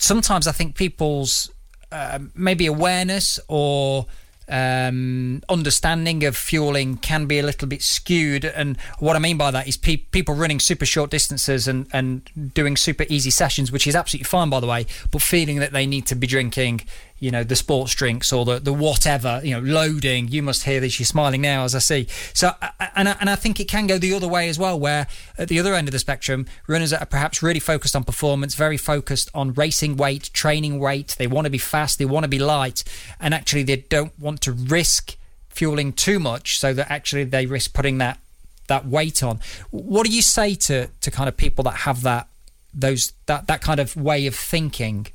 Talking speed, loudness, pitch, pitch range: 215 wpm, -20 LUFS, 140 Hz, 130-155 Hz